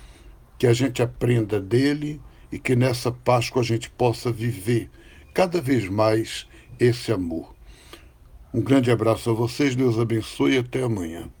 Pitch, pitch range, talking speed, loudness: 120 Hz, 110-125 Hz, 145 wpm, -23 LUFS